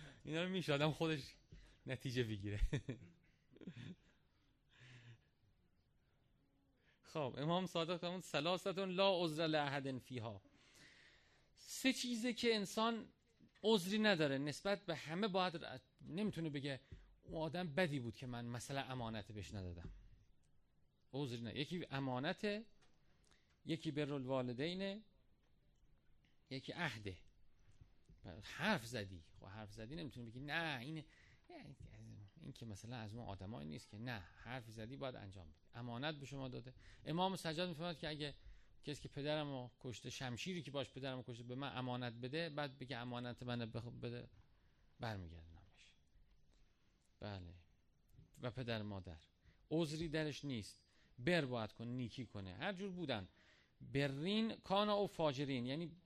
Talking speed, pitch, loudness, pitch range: 130 wpm, 130 Hz, -44 LUFS, 110-160 Hz